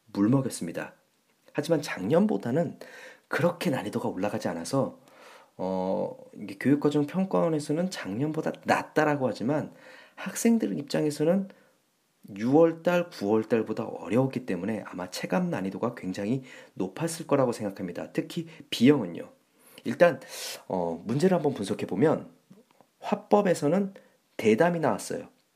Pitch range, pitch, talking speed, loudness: 130-185 Hz, 160 Hz, 290 characters per minute, -28 LUFS